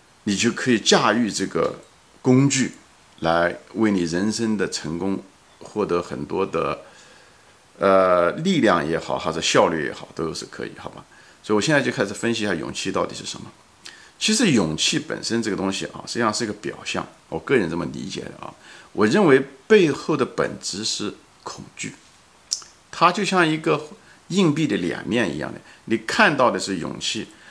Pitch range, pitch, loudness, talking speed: 85-140 Hz, 105 Hz, -21 LUFS, 255 characters per minute